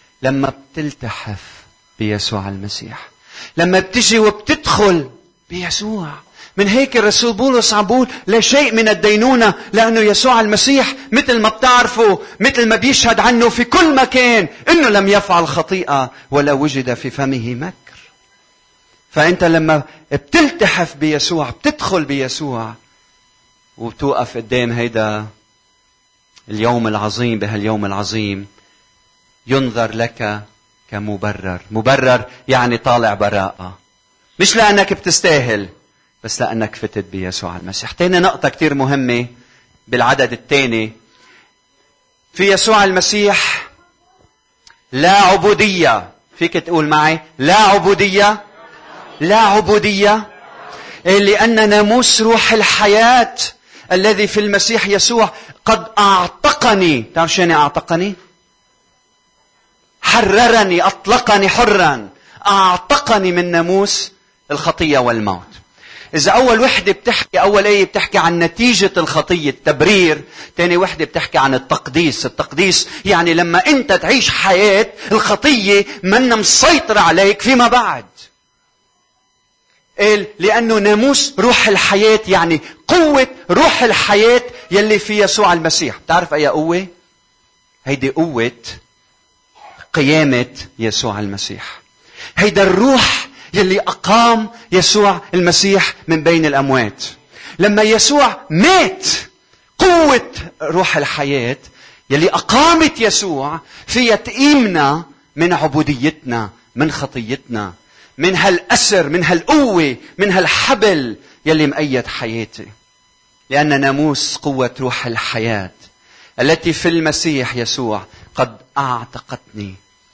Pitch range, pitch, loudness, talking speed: 130-210 Hz, 175 Hz, -13 LUFS, 100 wpm